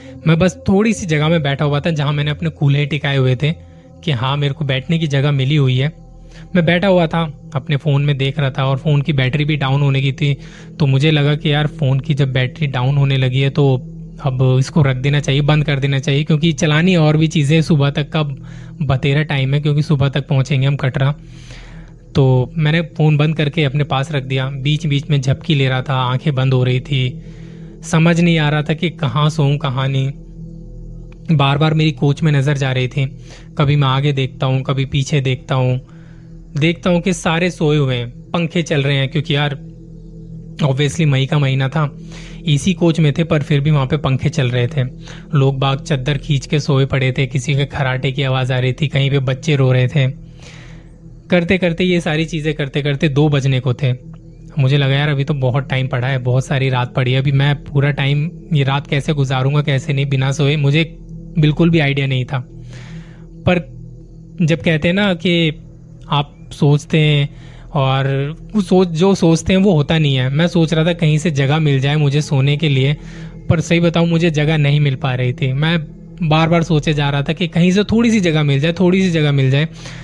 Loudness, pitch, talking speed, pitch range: -16 LUFS, 150 Hz, 220 wpm, 135-160 Hz